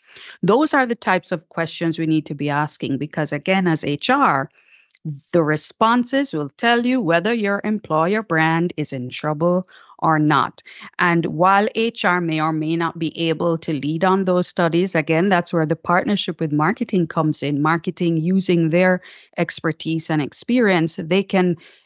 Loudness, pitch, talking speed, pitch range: -19 LUFS, 170 Hz, 165 wpm, 155-185 Hz